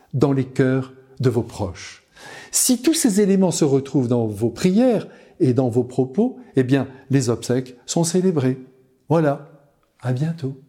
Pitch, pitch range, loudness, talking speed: 135 Hz, 130-170 Hz, -20 LUFS, 155 wpm